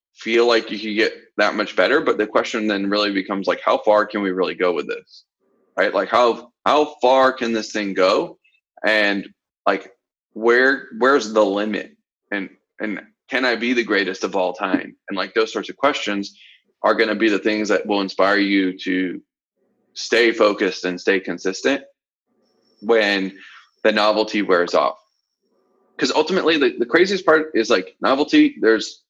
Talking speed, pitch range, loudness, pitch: 175 wpm, 100-140 Hz, -19 LUFS, 110 Hz